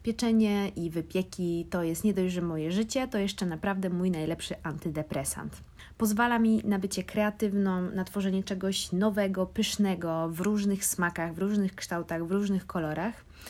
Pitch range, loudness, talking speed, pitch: 170-205 Hz, -30 LUFS, 155 wpm, 190 Hz